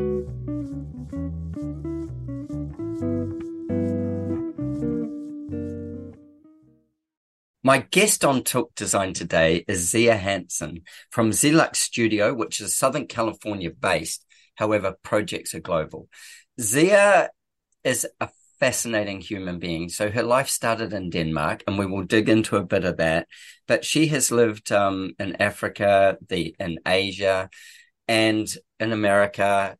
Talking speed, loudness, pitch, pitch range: 110 wpm, -23 LUFS, 105 Hz, 90-130 Hz